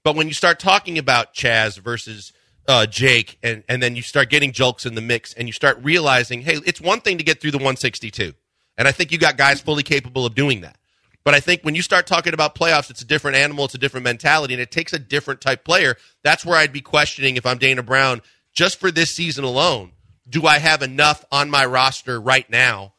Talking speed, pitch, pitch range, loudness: 240 wpm, 135 Hz, 125-155 Hz, -17 LUFS